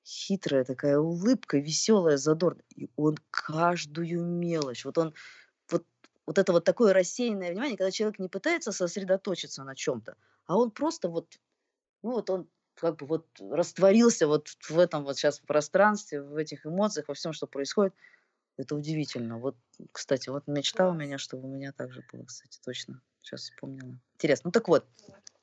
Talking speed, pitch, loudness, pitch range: 165 wpm, 165 Hz, -29 LUFS, 145-190 Hz